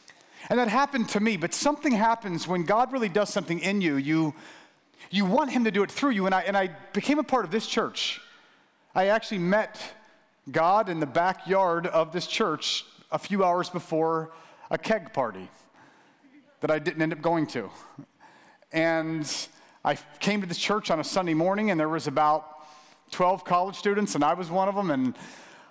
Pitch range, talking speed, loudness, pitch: 165-215 Hz, 195 wpm, -26 LUFS, 190 Hz